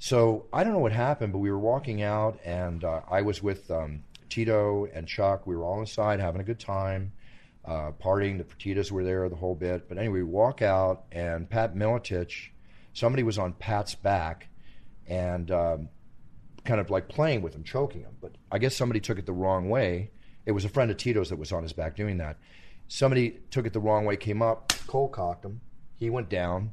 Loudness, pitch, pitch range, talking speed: -29 LUFS, 100 Hz, 90-110 Hz, 215 wpm